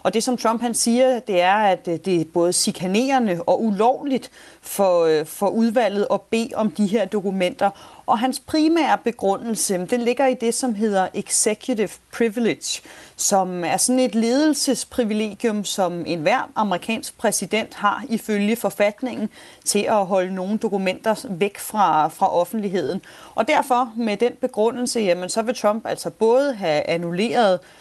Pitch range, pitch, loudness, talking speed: 190-240 Hz, 215 Hz, -21 LUFS, 150 wpm